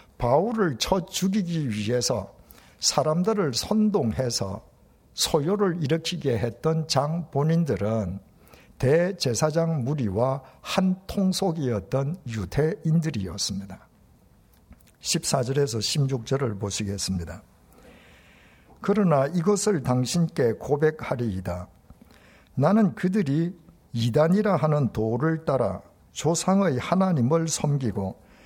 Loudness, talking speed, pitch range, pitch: -25 LUFS, 220 characters per minute, 110-170 Hz, 145 Hz